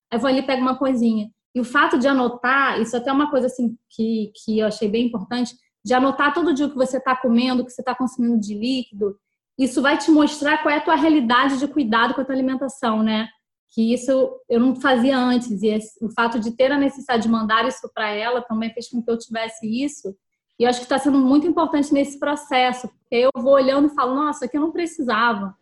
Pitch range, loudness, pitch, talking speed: 230-275 Hz, -20 LUFS, 250 Hz, 240 wpm